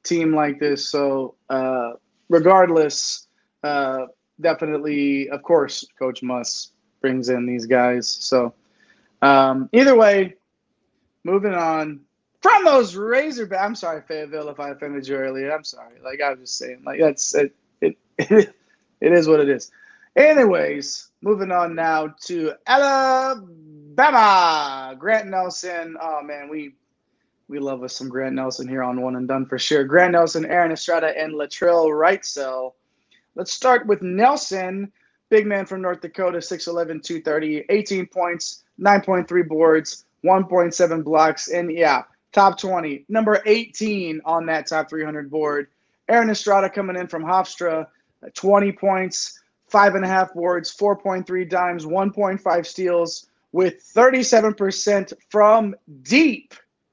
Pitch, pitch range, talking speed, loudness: 170 Hz, 145-200 Hz, 135 wpm, -19 LUFS